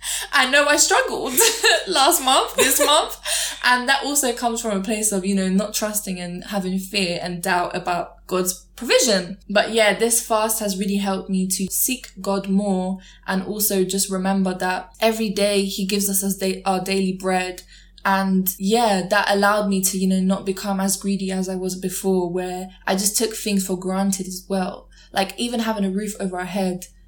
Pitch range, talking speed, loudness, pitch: 185-210 Hz, 195 wpm, -20 LUFS, 195 Hz